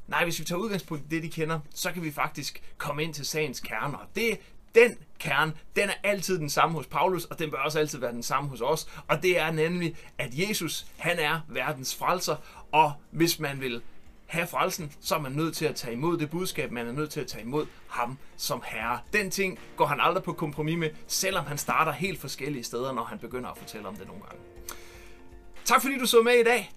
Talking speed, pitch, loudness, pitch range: 235 wpm, 155 Hz, -28 LUFS, 140-175 Hz